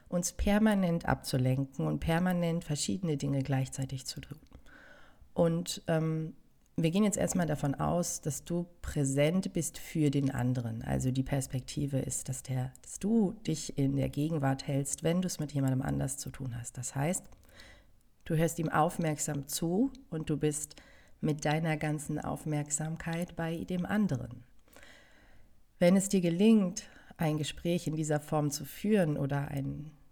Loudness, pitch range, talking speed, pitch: -32 LUFS, 135-170 Hz, 155 wpm, 150 Hz